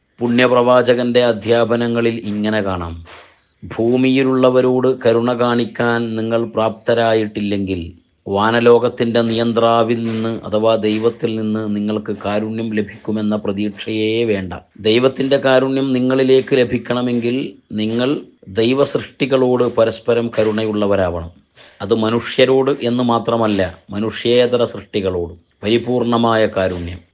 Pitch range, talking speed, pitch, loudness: 105-120 Hz, 80 wpm, 115 Hz, -16 LUFS